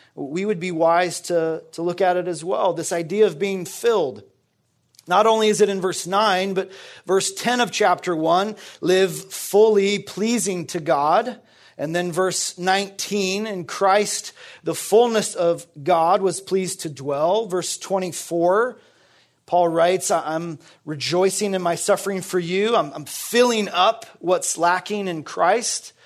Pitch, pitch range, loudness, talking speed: 185 Hz, 175-205 Hz, -21 LUFS, 155 wpm